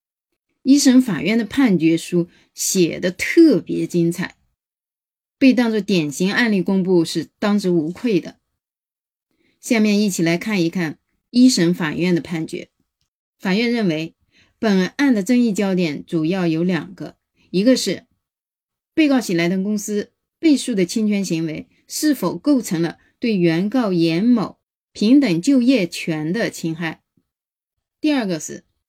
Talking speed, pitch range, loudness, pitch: 205 characters per minute, 170-240 Hz, -18 LUFS, 185 Hz